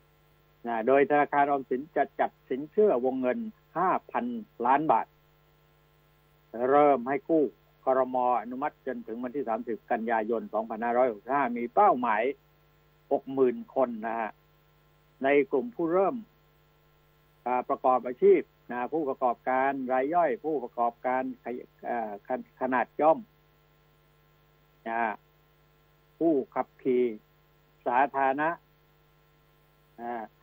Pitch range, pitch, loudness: 125-150 Hz, 135 Hz, -28 LUFS